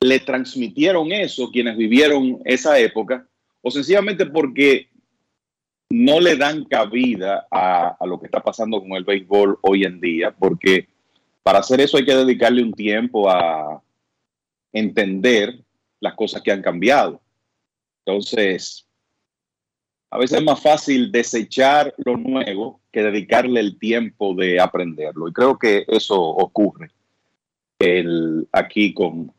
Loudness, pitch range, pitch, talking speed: -18 LUFS, 100-130 Hz, 120 Hz, 135 wpm